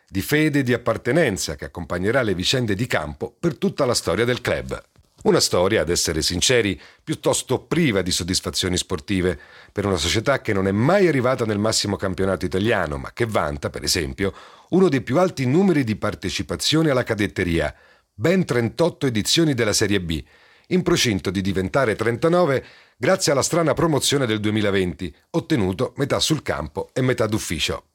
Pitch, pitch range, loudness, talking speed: 110 Hz, 95-140 Hz, -21 LUFS, 165 wpm